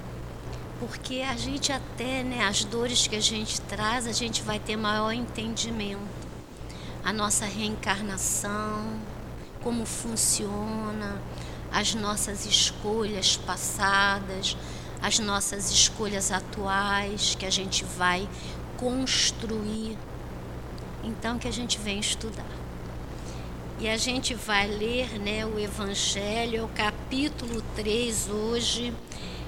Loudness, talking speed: -27 LUFS, 110 wpm